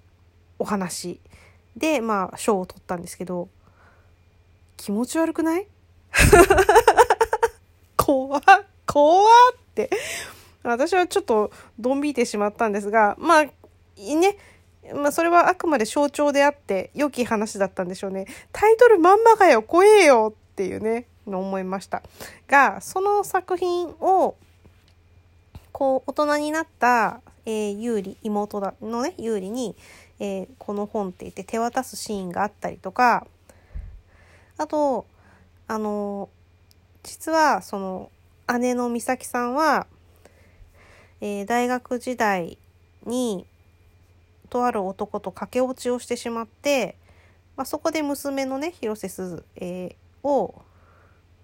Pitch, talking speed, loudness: 220 Hz, 235 characters per minute, -21 LUFS